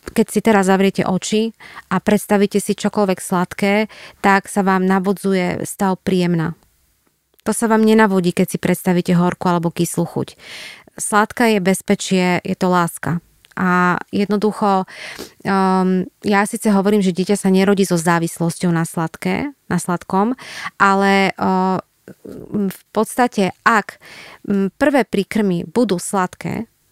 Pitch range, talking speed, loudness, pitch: 180-210 Hz, 125 wpm, -17 LUFS, 195 Hz